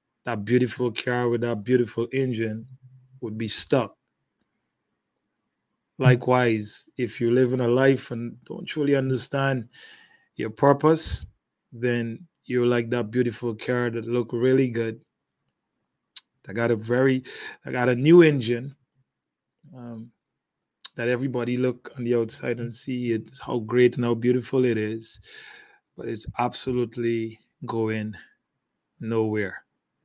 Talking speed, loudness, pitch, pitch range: 130 wpm, -24 LUFS, 120 Hz, 115-130 Hz